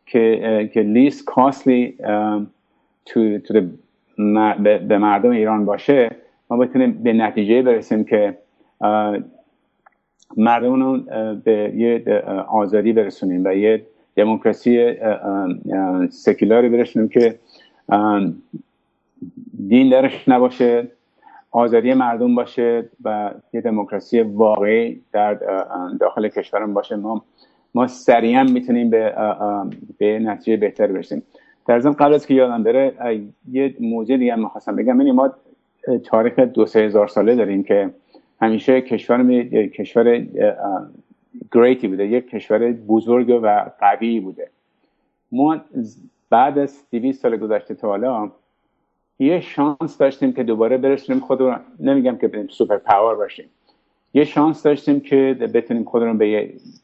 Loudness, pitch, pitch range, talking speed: -17 LUFS, 120 Hz, 110-135 Hz, 120 wpm